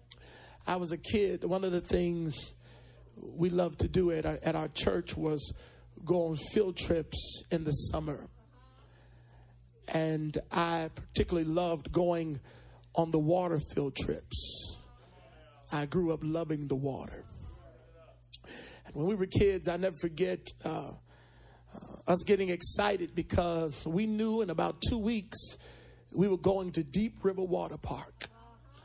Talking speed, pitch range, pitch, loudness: 145 wpm, 135-180 Hz, 165 Hz, -32 LUFS